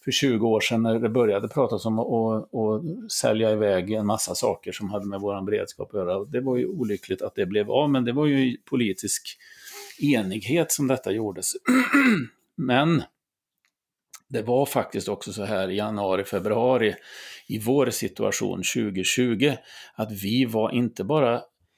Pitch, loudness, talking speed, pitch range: 115 Hz, -24 LUFS, 165 wpm, 105-130 Hz